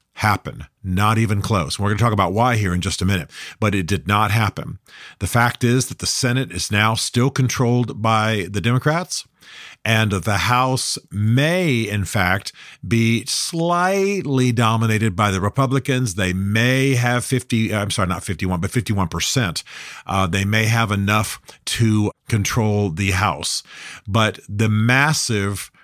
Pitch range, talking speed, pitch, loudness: 100-125 Hz, 155 wpm, 110 Hz, -19 LUFS